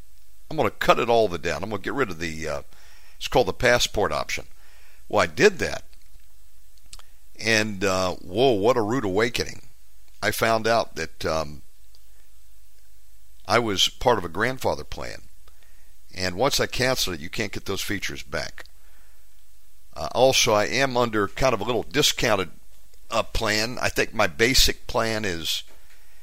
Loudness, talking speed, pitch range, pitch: -23 LUFS, 165 wpm, 90-110 Hz, 100 Hz